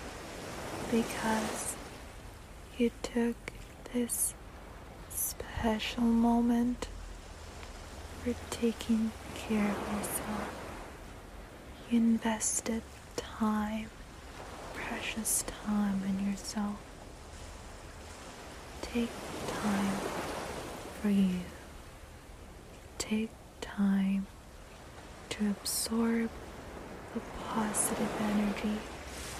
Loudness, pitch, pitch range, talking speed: -33 LUFS, 215 Hz, 180-230 Hz, 60 wpm